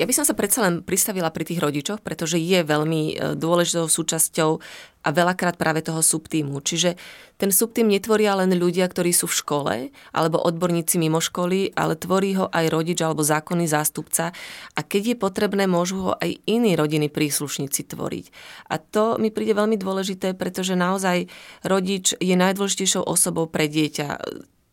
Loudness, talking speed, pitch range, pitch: -22 LUFS, 165 wpm, 160-195 Hz, 175 Hz